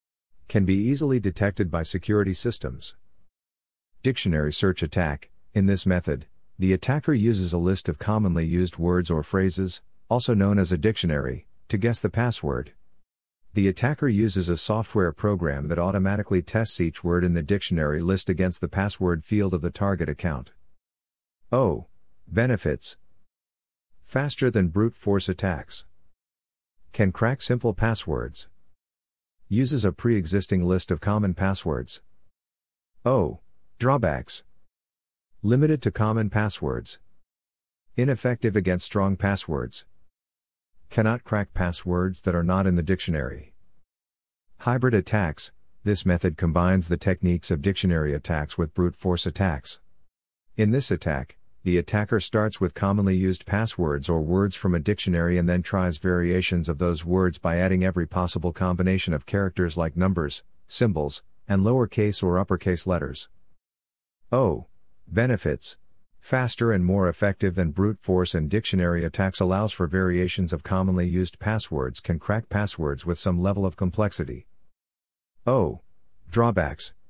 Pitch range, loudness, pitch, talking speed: 80-100 Hz, -25 LUFS, 90 Hz, 135 wpm